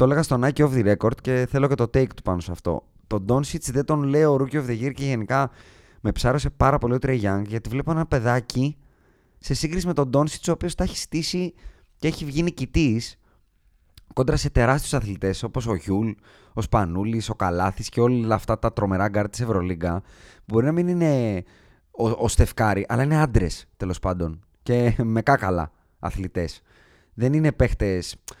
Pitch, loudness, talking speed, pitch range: 120 Hz, -23 LUFS, 195 wpm, 95-140 Hz